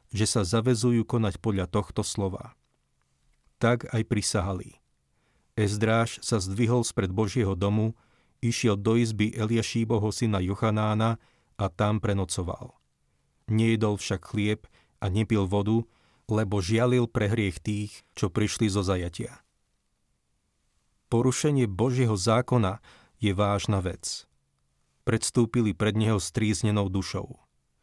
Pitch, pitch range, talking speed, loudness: 110 Hz, 100-115 Hz, 110 wpm, -27 LUFS